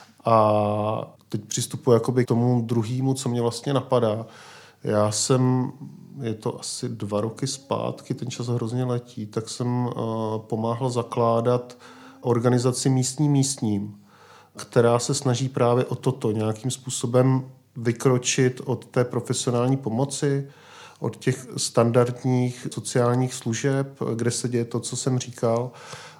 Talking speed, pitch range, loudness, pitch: 125 wpm, 115-130 Hz, -24 LUFS, 125 Hz